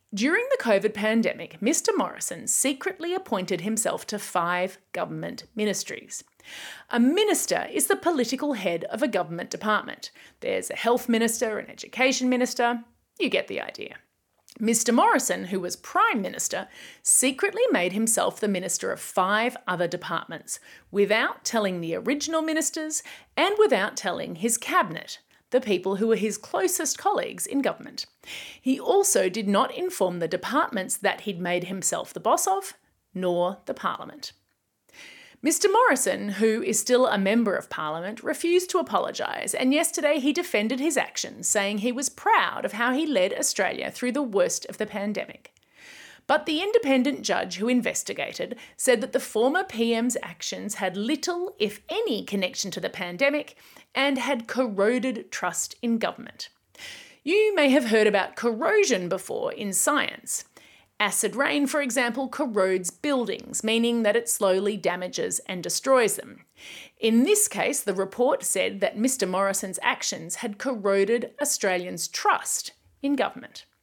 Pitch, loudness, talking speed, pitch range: 240 Hz, -25 LUFS, 150 wpm, 205-295 Hz